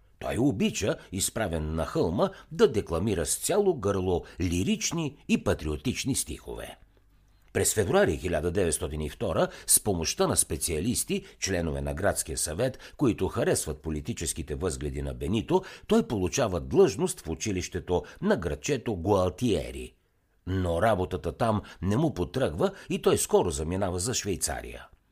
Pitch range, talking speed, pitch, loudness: 80-125 Hz, 120 wpm, 90 Hz, -28 LUFS